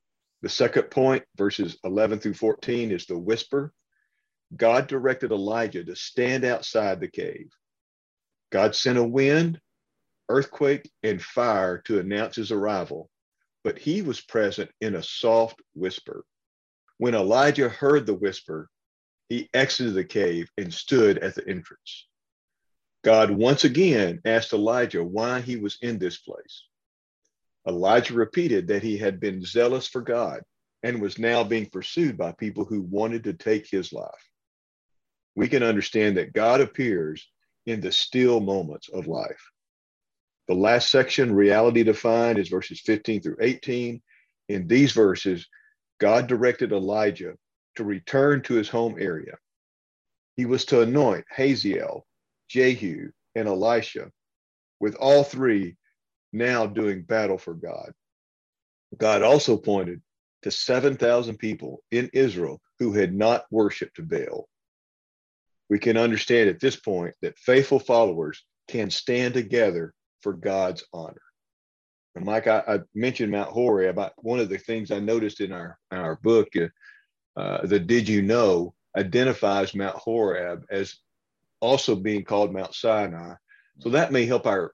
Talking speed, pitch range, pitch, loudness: 140 wpm, 100-125 Hz, 110 Hz, -24 LUFS